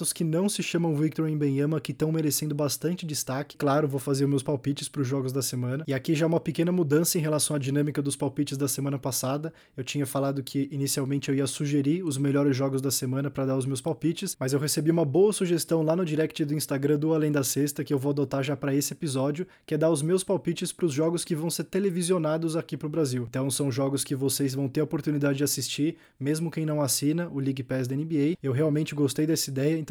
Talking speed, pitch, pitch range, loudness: 245 wpm, 150 Hz, 140-160 Hz, -27 LUFS